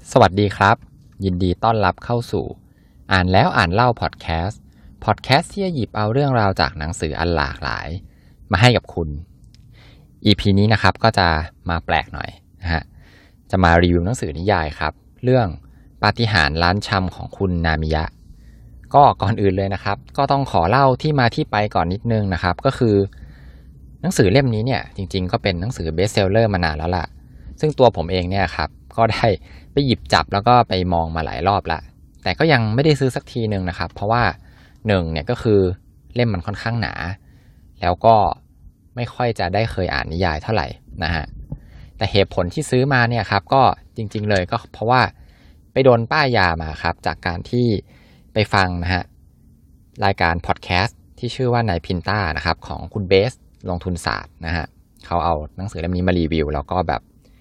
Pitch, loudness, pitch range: 95 Hz, -19 LUFS, 85-115 Hz